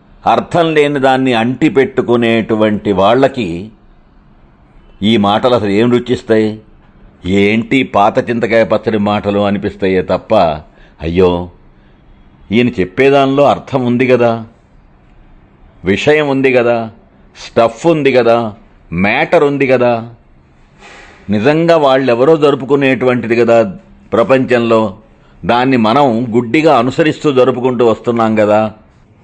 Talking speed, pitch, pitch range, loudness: 90 wpm, 115 Hz, 105-130 Hz, -11 LUFS